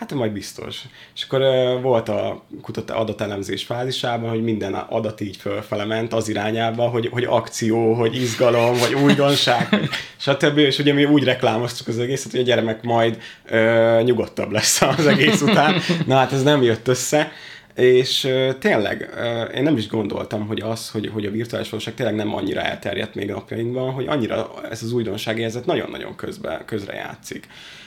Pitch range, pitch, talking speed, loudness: 110-130 Hz, 115 Hz, 175 wpm, -20 LUFS